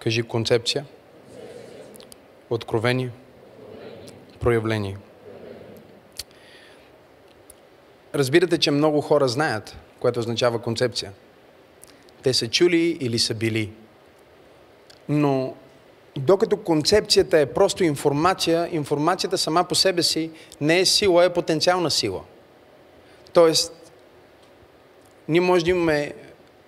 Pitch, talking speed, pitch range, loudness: 155 Hz, 90 wpm, 120-175 Hz, -21 LUFS